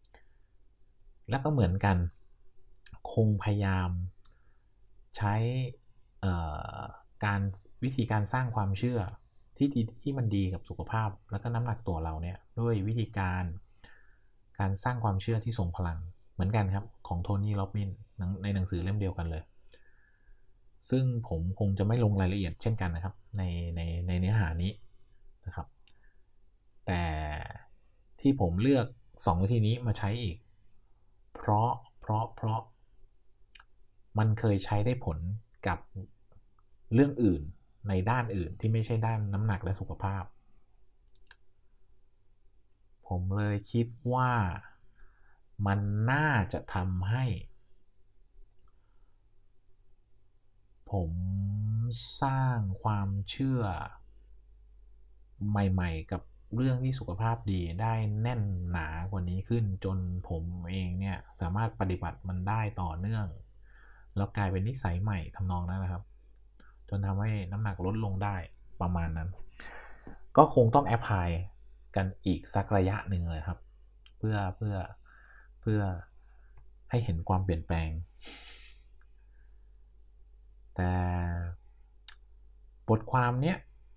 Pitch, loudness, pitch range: 100 Hz, -32 LUFS, 95-110 Hz